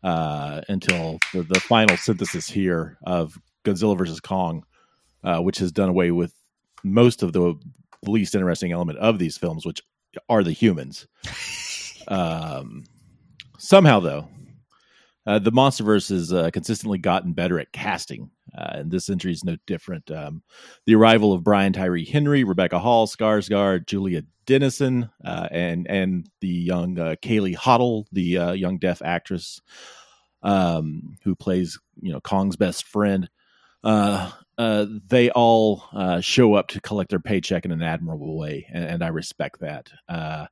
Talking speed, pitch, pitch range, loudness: 155 wpm, 95 Hz, 85-110 Hz, -22 LUFS